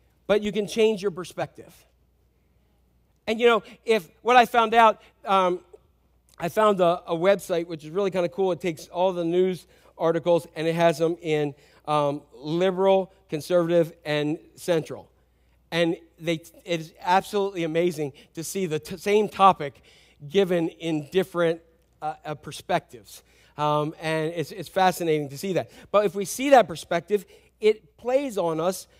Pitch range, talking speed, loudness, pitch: 155-195 Hz, 160 wpm, -24 LUFS, 170 Hz